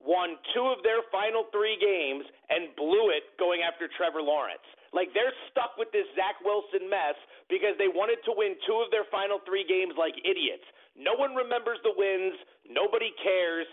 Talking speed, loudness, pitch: 185 wpm, -29 LUFS, 205 Hz